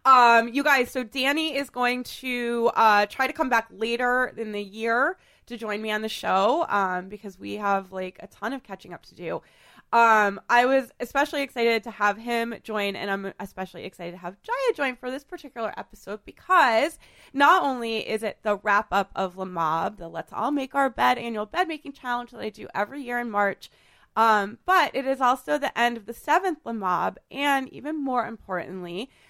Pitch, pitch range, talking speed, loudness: 230 Hz, 205-265 Hz, 205 wpm, -24 LUFS